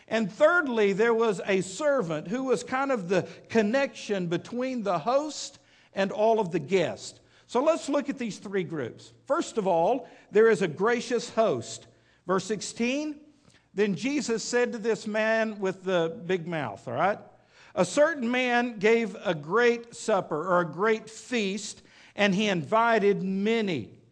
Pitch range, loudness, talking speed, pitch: 190-240 Hz, -27 LUFS, 160 wpm, 220 Hz